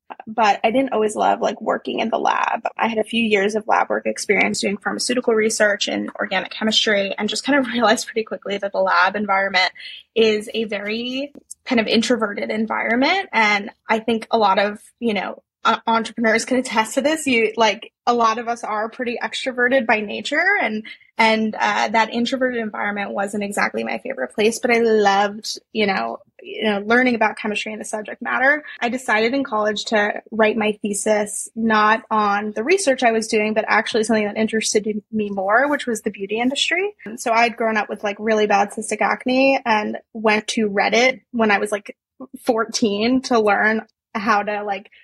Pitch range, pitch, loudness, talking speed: 210-240 Hz, 220 Hz, -19 LUFS, 190 wpm